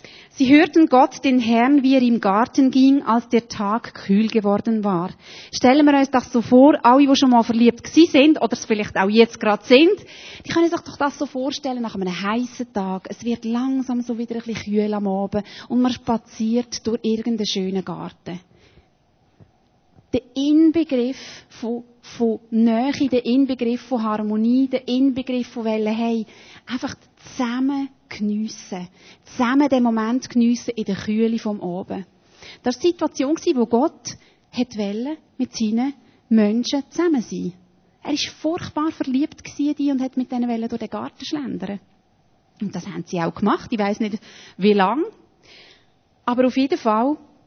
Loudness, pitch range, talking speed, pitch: -20 LUFS, 215-270 Hz, 165 wpm, 240 Hz